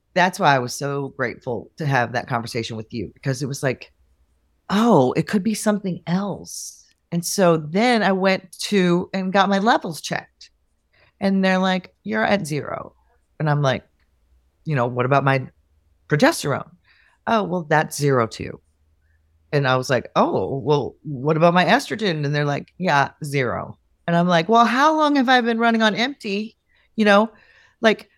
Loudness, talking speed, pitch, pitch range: -20 LUFS, 175 wpm, 155 Hz, 120-195 Hz